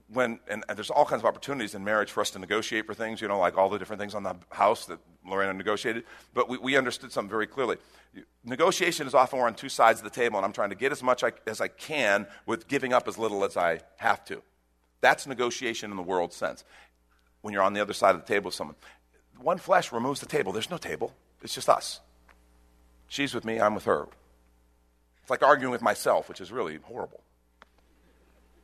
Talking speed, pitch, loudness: 230 wpm, 95 Hz, -28 LUFS